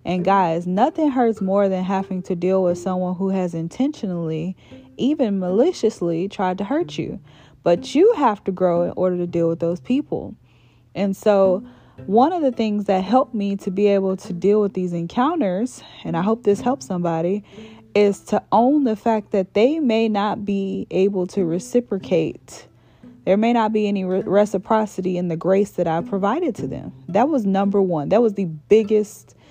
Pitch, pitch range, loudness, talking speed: 195 Hz, 180-220 Hz, -20 LUFS, 185 wpm